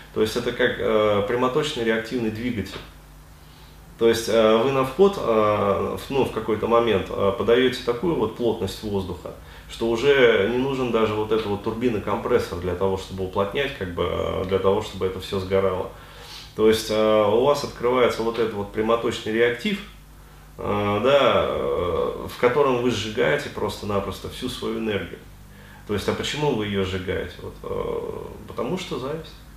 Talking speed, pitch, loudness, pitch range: 165 wpm, 110 Hz, -23 LUFS, 100-125 Hz